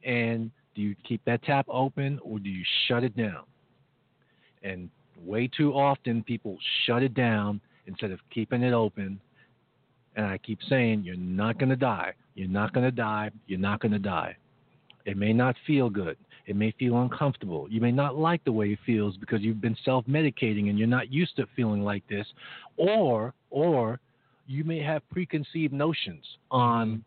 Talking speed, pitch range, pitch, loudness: 180 wpm, 105-135 Hz, 120 Hz, -28 LUFS